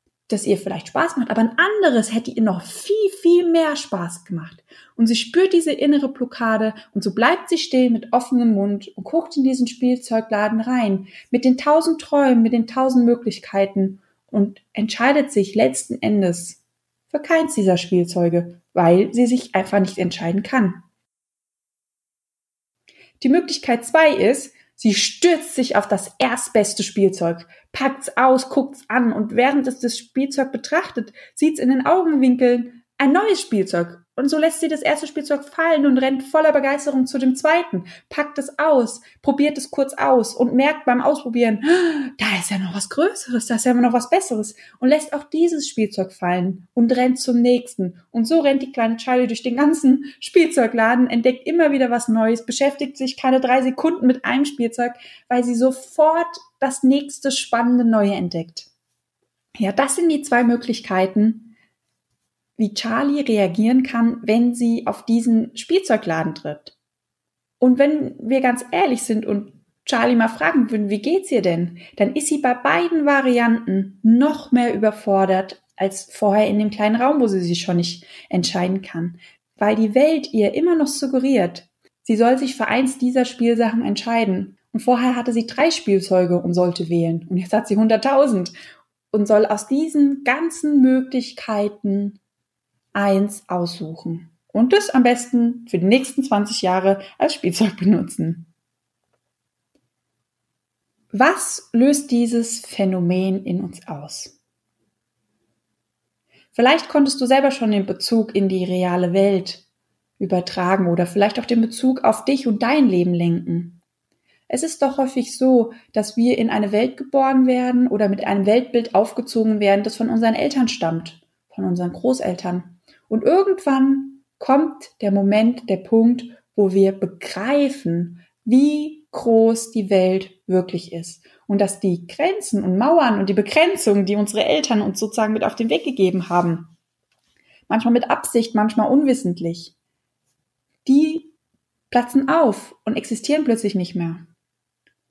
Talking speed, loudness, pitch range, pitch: 155 wpm, -19 LUFS, 195-270 Hz, 235 Hz